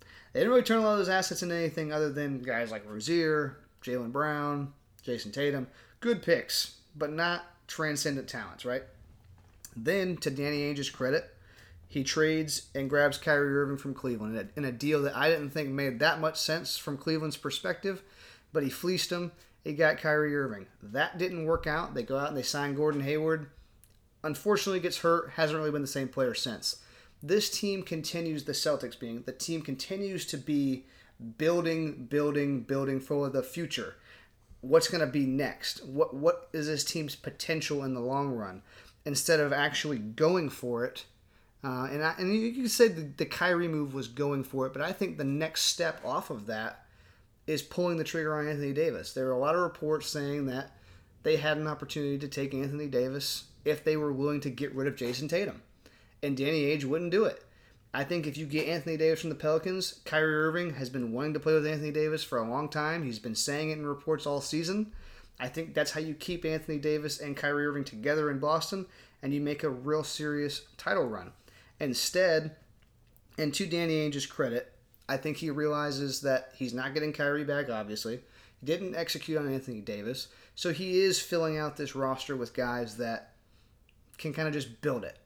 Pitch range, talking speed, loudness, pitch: 130-160 Hz, 195 wpm, -31 LUFS, 145 Hz